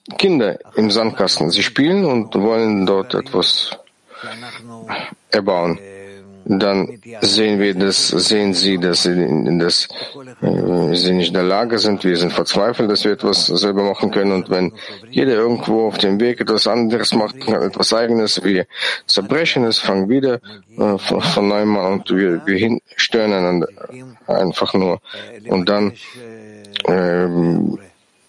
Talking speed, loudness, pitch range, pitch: 140 wpm, -16 LUFS, 95-115 Hz, 100 Hz